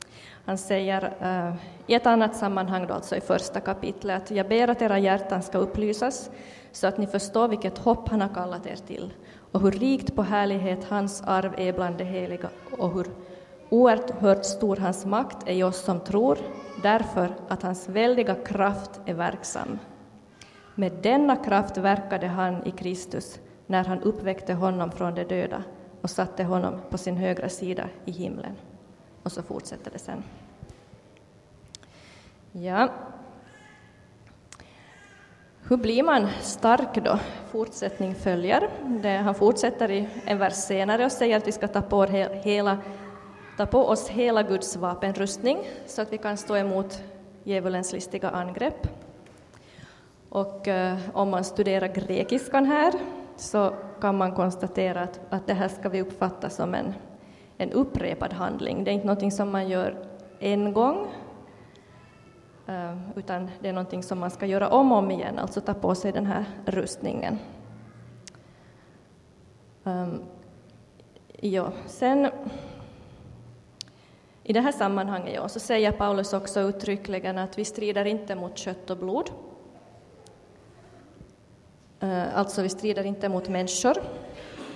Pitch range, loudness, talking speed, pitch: 185-210 Hz, -26 LUFS, 145 wpm, 195 Hz